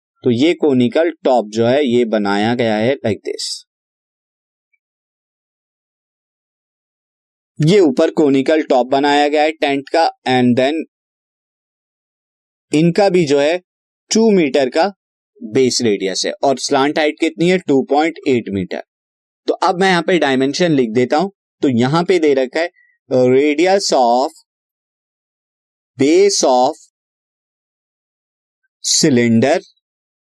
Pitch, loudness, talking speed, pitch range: 145 Hz, -15 LUFS, 125 wpm, 125-180 Hz